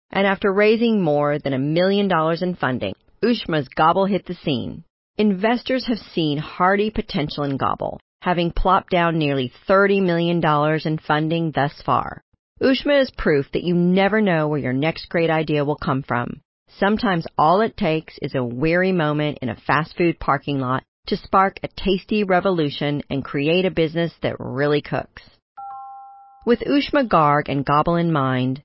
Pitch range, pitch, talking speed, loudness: 145-195 Hz, 170 Hz, 170 wpm, -20 LUFS